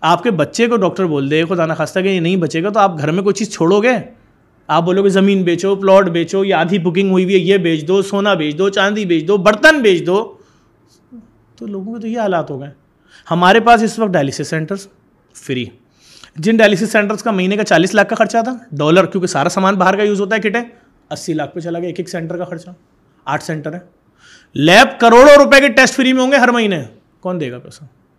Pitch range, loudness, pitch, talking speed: 165-215 Hz, -13 LUFS, 190 Hz, 235 wpm